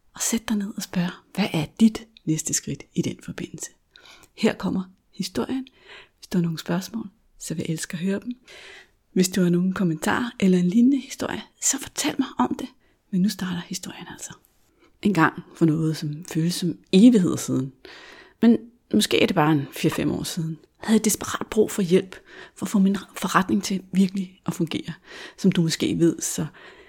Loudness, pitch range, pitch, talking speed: -23 LUFS, 170-225 Hz, 190 Hz, 195 wpm